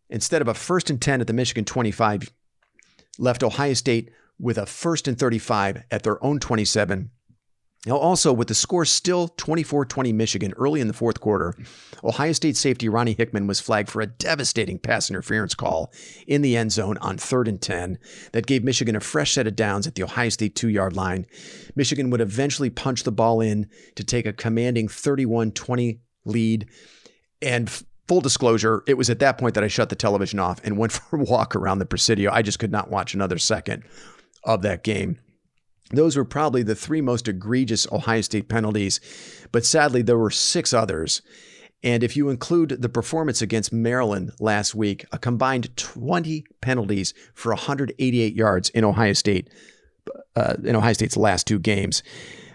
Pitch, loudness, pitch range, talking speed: 115 Hz, -22 LUFS, 105-130 Hz, 185 wpm